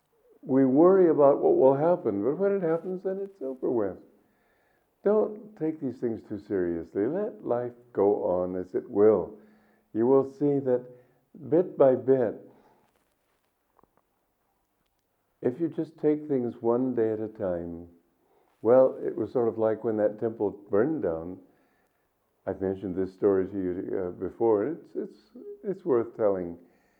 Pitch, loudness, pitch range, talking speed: 125 Hz, -27 LUFS, 105-165 Hz, 150 wpm